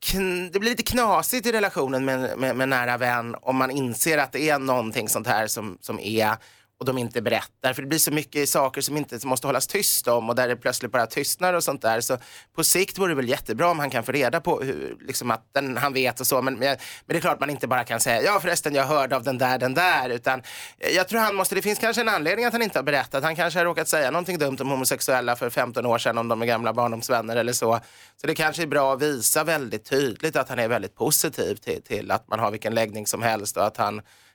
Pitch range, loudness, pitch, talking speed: 120-165 Hz, -23 LUFS, 135 Hz, 265 wpm